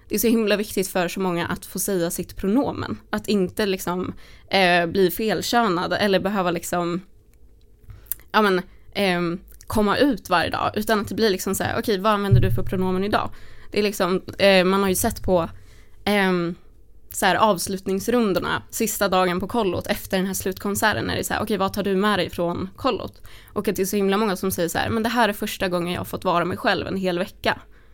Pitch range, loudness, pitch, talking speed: 175-210 Hz, -22 LUFS, 190 Hz, 220 wpm